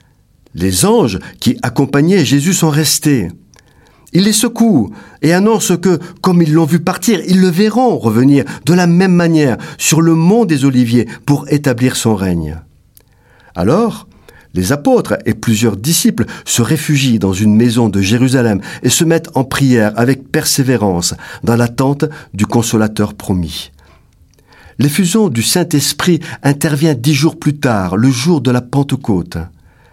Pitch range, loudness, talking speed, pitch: 115-165 Hz, -12 LUFS, 145 wpm, 135 Hz